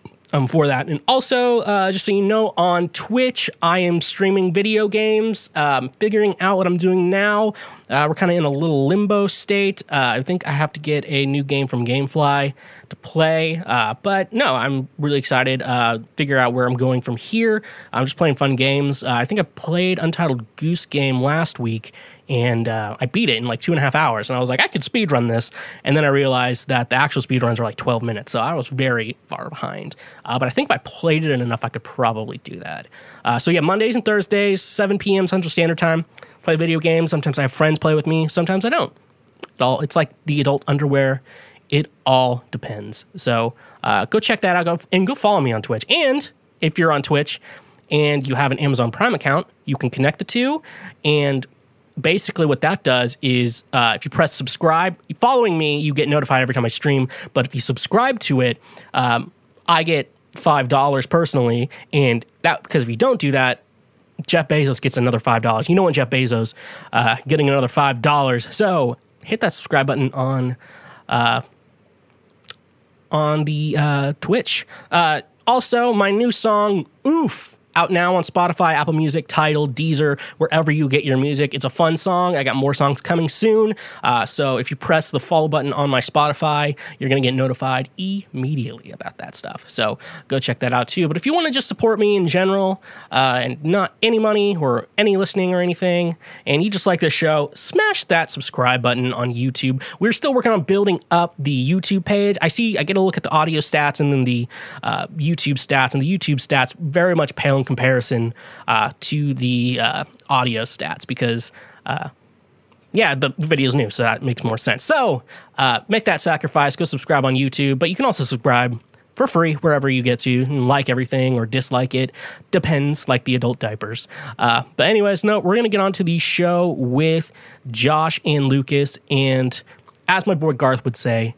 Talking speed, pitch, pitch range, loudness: 205 wpm, 150 Hz, 130-180 Hz, -18 LUFS